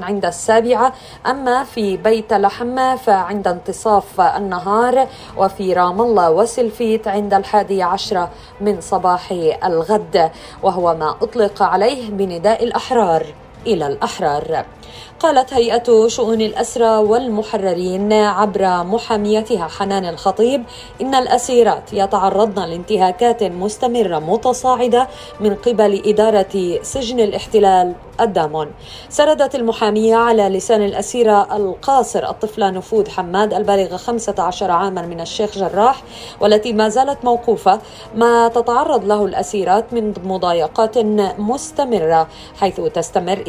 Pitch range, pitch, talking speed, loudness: 190-235 Hz, 210 Hz, 105 wpm, -16 LUFS